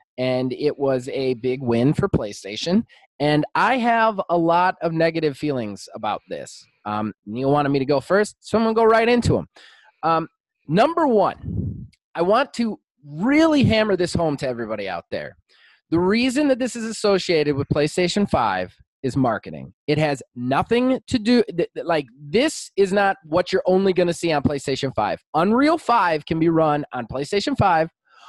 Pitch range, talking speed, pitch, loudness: 140-215 Hz, 180 wpm, 165 Hz, -21 LUFS